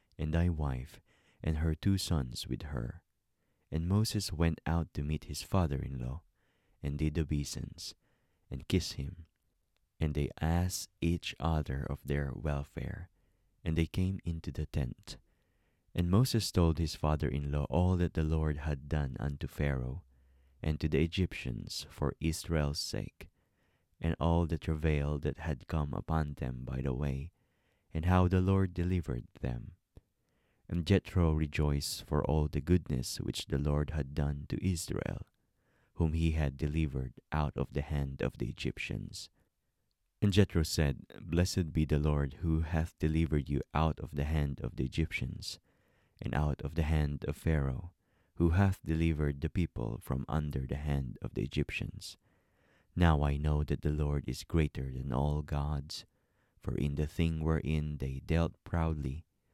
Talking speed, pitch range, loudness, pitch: 160 wpm, 70-85 Hz, -34 LUFS, 75 Hz